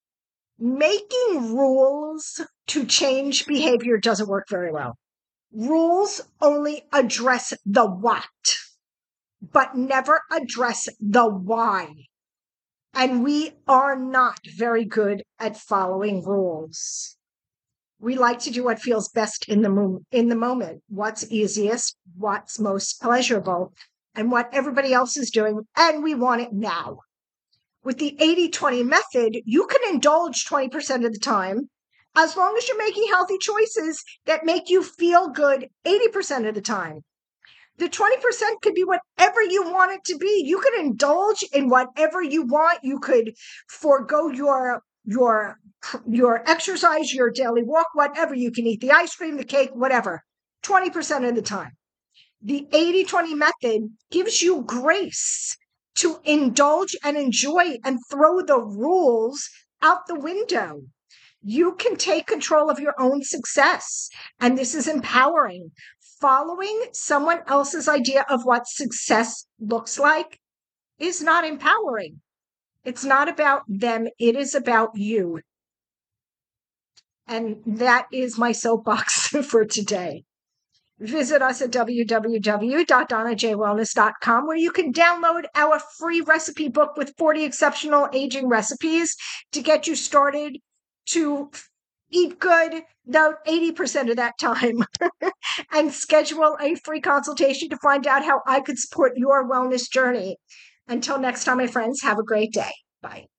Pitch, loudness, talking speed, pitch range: 275 Hz, -21 LUFS, 140 wpm, 235-320 Hz